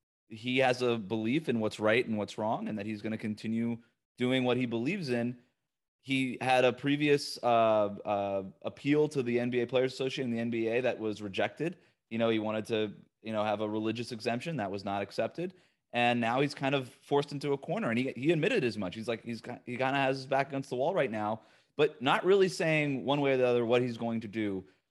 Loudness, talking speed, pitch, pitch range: -31 LUFS, 235 wpm, 120 Hz, 110-135 Hz